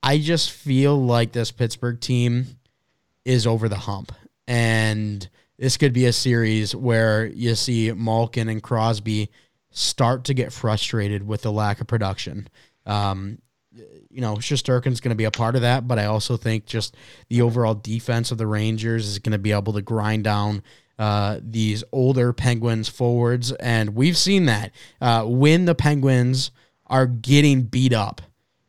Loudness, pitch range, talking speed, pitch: -21 LUFS, 110-125 Hz, 165 wpm, 115 Hz